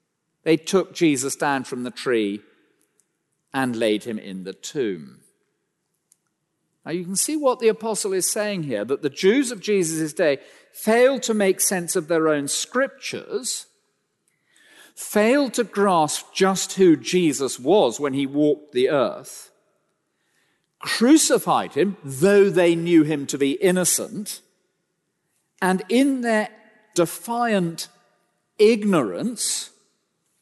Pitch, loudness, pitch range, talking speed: 185 Hz, -21 LUFS, 155-220 Hz, 125 wpm